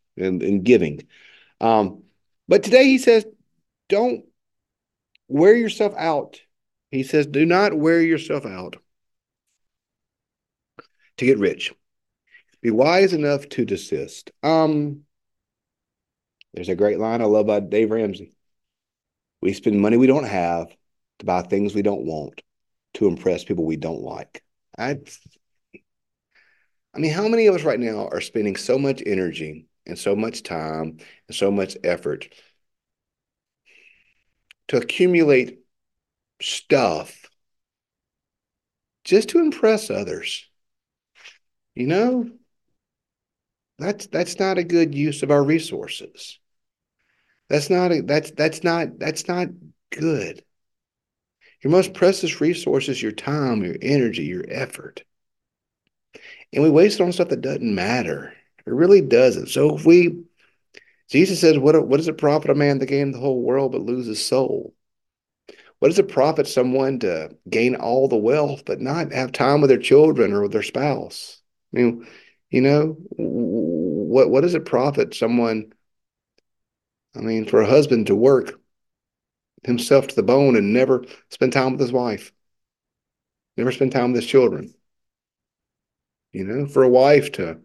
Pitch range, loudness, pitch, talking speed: 115-180 Hz, -19 LUFS, 145 Hz, 140 wpm